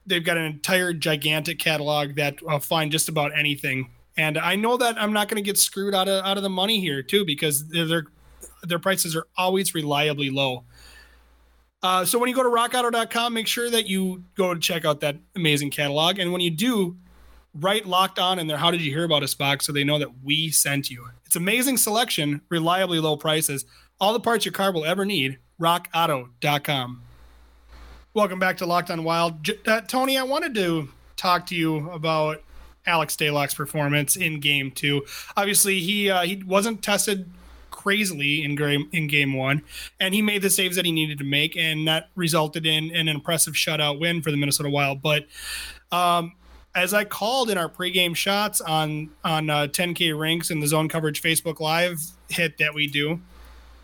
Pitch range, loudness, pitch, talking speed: 150-190 Hz, -22 LUFS, 165 Hz, 195 wpm